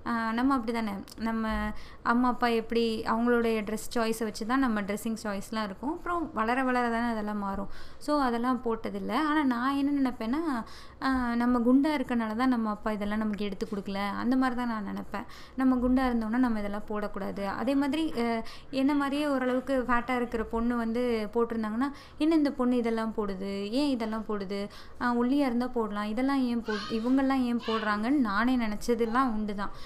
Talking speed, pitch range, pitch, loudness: 160 wpm, 220-260 Hz, 235 Hz, -29 LUFS